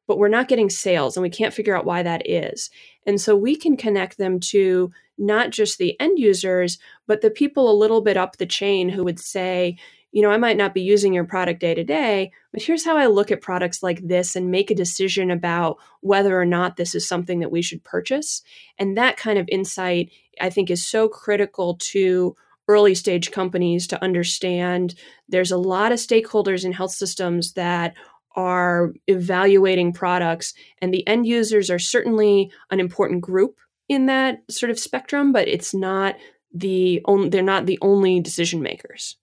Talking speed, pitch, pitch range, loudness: 195 wpm, 190 Hz, 180-210 Hz, -20 LUFS